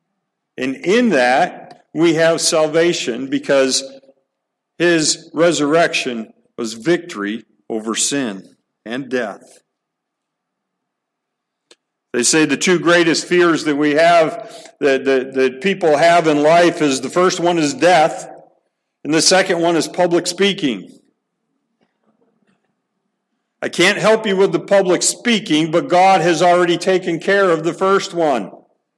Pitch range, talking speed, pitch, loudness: 150-180 Hz, 130 wpm, 170 Hz, -15 LUFS